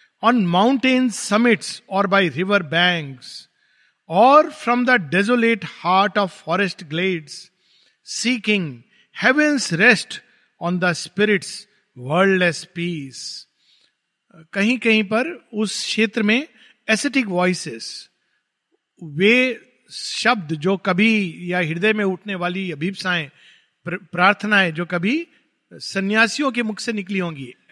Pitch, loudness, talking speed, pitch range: 195 Hz, -19 LUFS, 105 wpm, 175-230 Hz